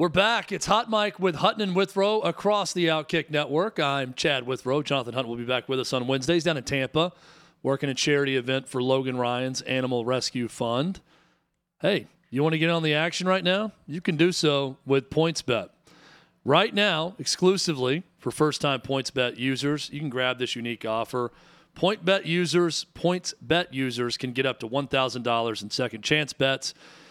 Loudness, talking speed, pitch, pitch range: -25 LUFS, 185 wpm, 145 Hz, 130-175 Hz